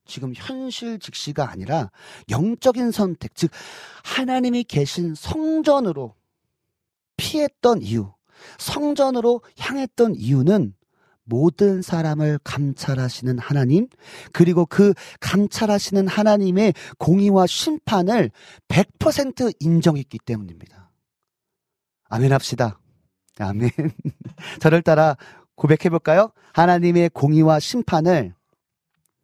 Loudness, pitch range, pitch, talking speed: -20 LUFS, 140-215 Hz, 170 Hz, 225 characters per minute